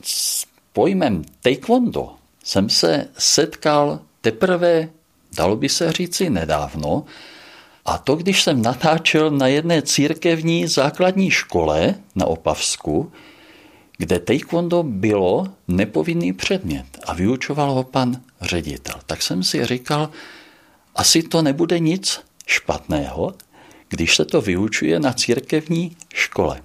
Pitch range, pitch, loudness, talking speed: 125-170 Hz, 150 Hz, -19 LUFS, 115 wpm